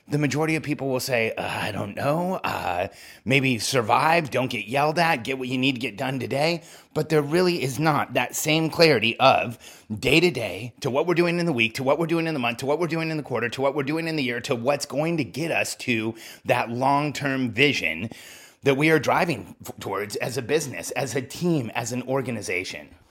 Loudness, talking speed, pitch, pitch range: -24 LUFS, 235 wpm, 140 Hz, 125-160 Hz